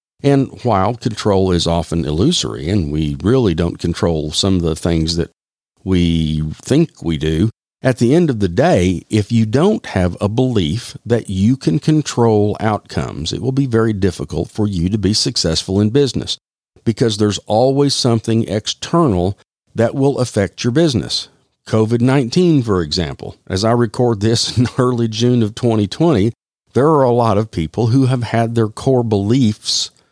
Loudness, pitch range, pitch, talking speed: -16 LUFS, 90-125 Hz, 110 Hz, 165 wpm